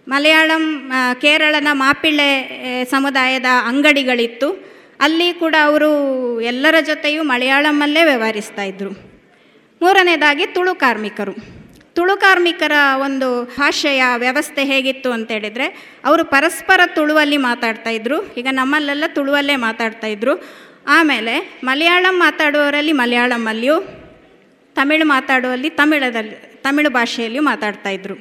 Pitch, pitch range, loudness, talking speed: 280 Hz, 245-310 Hz, -14 LUFS, 90 wpm